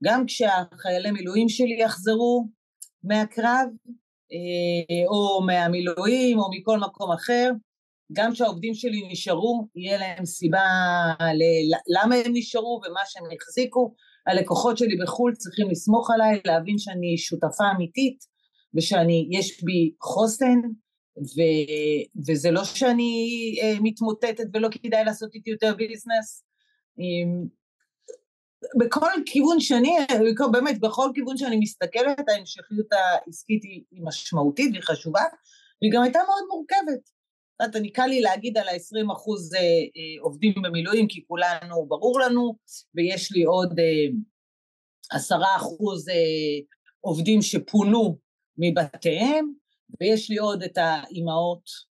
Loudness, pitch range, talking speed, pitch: -24 LUFS, 175-240 Hz, 110 wpm, 215 Hz